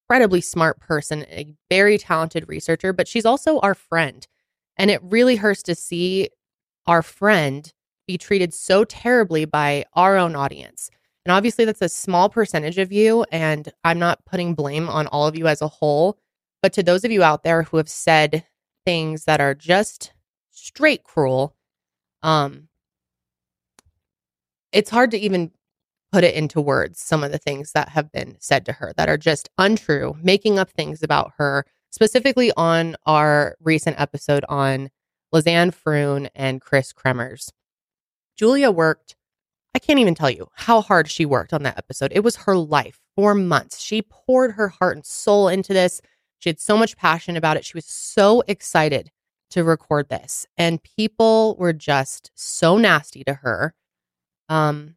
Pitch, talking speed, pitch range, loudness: 165 Hz, 170 wpm, 145-195 Hz, -19 LUFS